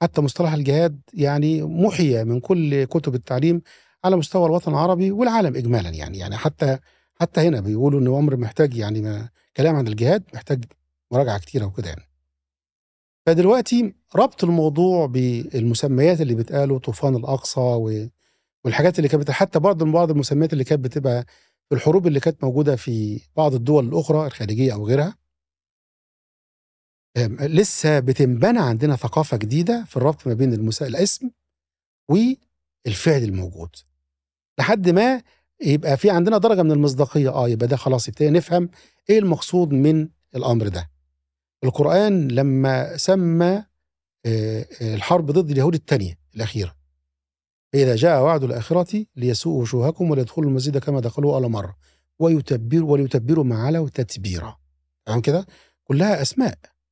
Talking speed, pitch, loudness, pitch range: 130 wpm, 140 Hz, -20 LUFS, 115-165 Hz